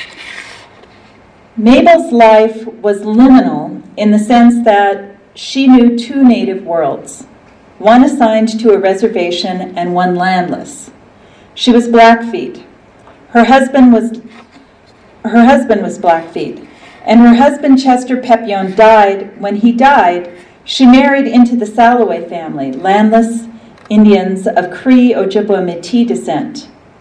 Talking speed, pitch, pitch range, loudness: 120 wpm, 225 Hz, 200-245 Hz, -9 LUFS